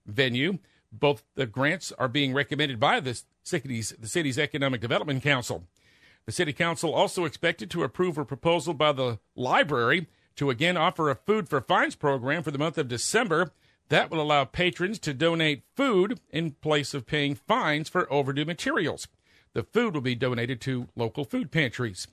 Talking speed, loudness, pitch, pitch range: 175 wpm, -27 LUFS, 150 Hz, 135-170 Hz